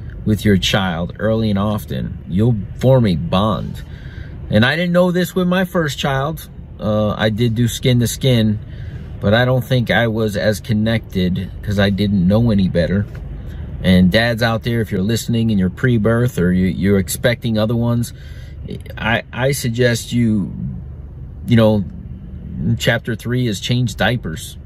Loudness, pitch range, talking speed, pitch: -17 LUFS, 100-120 Hz, 165 wpm, 110 Hz